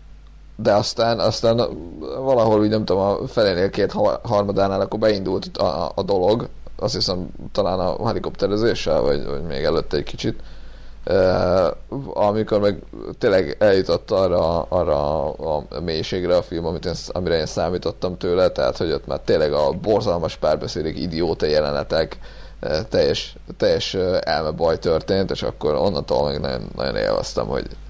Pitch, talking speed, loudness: 115 Hz, 145 wpm, -21 LUFS